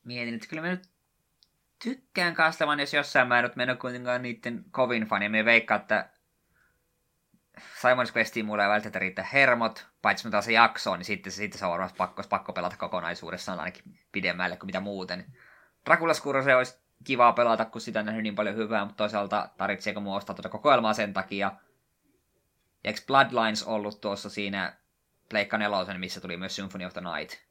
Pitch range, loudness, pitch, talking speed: 100-125 Hz, -27 LUFS, 110 Hz, 180 wpm